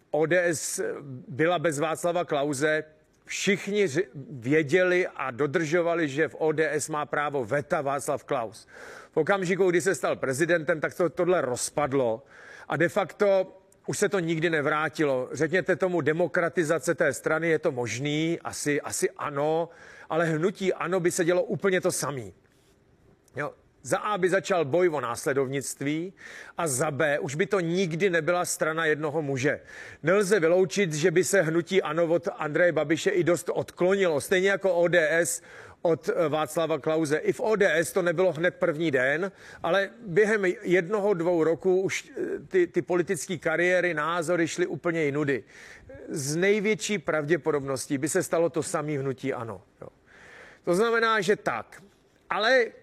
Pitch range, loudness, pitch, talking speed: 155-185 Hz, -26 LUFS, 170 Hz, 150 wpm